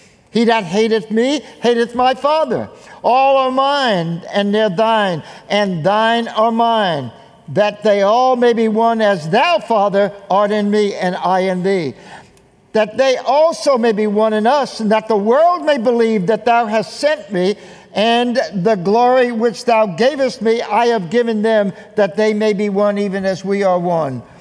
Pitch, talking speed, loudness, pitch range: 220 Hz, 180 wpm, -15 LUFS, 200-235 Hz